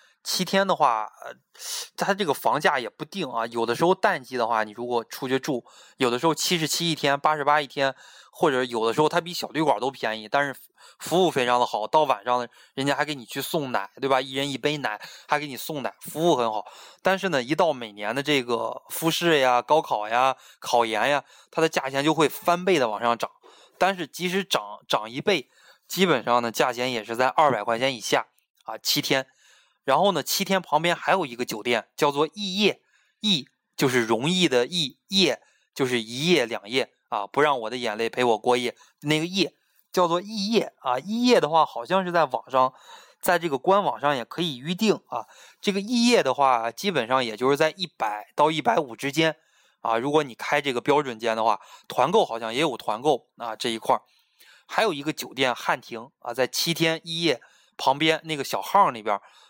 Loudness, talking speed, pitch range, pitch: -24 LUFS, 290 characters per minute, 125-170 Hz, 145 Hz